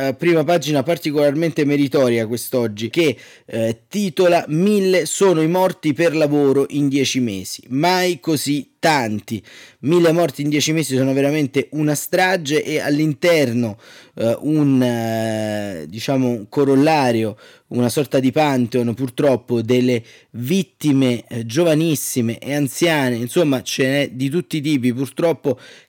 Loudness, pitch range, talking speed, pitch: -18 LUFS, 120-155 Hz, 130 wpm, 140 Hz